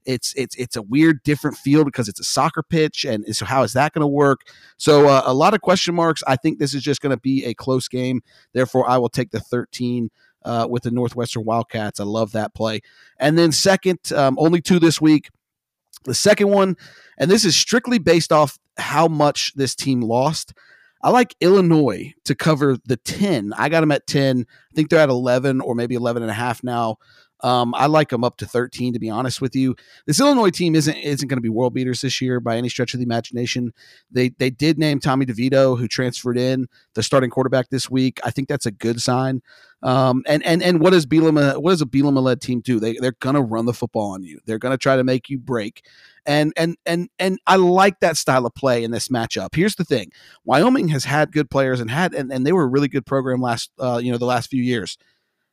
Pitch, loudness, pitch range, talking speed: 130 Hz, -19 LUFS, 120-155 Hz, 230 wpm